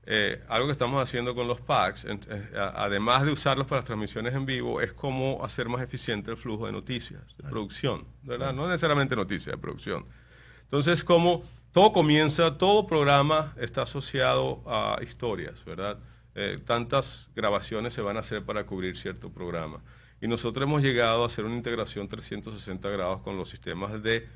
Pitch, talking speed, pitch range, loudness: 120 Hz, 175 wpm, 110-140 Hz, -28 LUFS